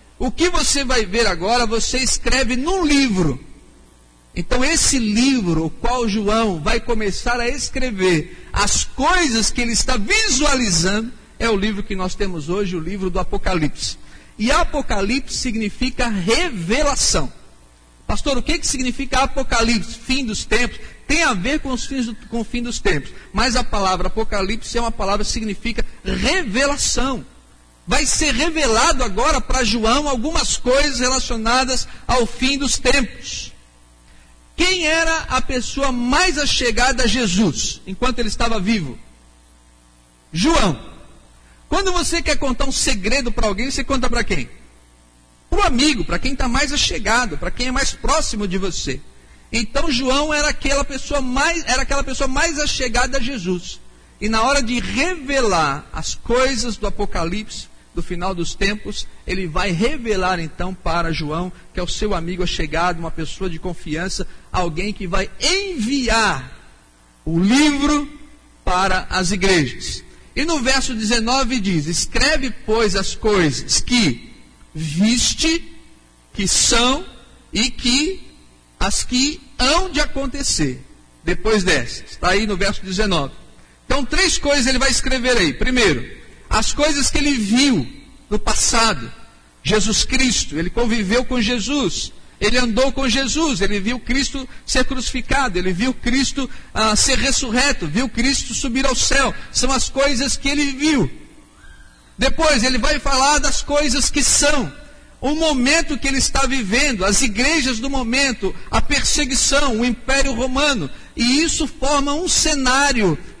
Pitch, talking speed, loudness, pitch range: 245 Hz, 145 wpm, -18 LUFS, 195-275 Hz